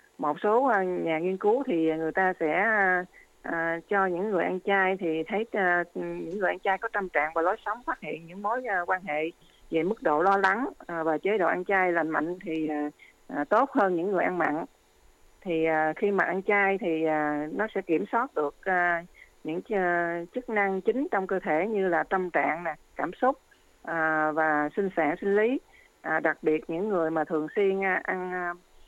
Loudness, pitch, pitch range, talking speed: -27 LUFS, 180 Hz, 160-195 Hz, 185 wpm